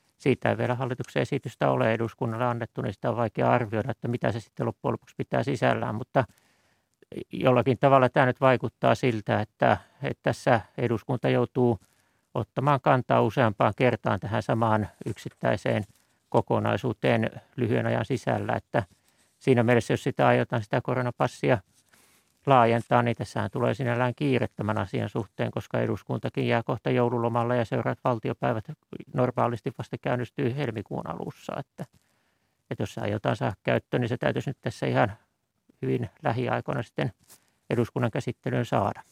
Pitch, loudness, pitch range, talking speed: 120 Hz, -27 LUFS, 115-130 Hz, 140 wpm